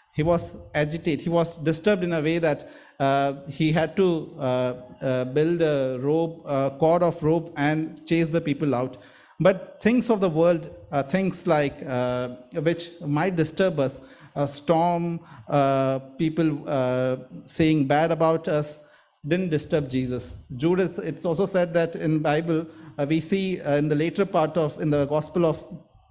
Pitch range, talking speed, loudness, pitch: 145-170 Hz, 170 wpm, -24 LUFS, 155 Hz